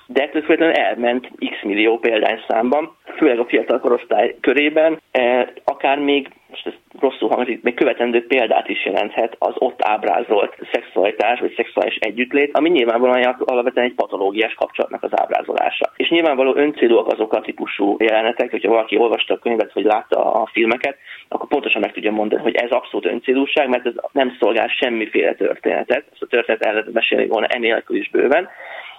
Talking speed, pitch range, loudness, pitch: 155 wpm, 125-160 Hz, -18 LUFS, 135 Hz